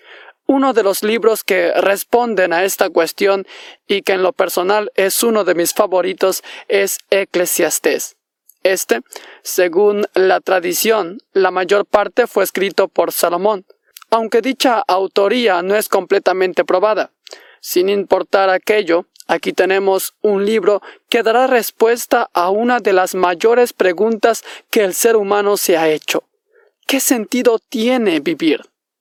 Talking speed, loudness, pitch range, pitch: 135 wpm, -15 LUFS, 185-230 Hz, 205 Hz